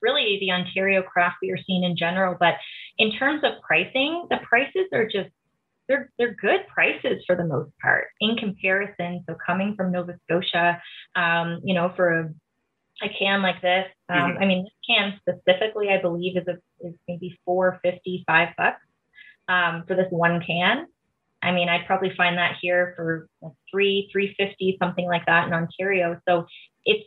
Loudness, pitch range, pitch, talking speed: -23 LUFS, 175-195 Hz, 180 Hz, 180 wpm